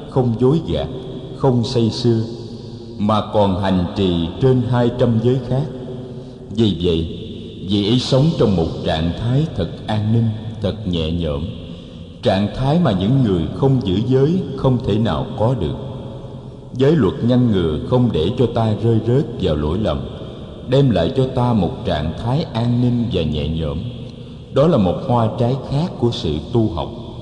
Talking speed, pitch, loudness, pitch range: 175 wpm, 115 Hz, -18 LUFS, 95-130 Hz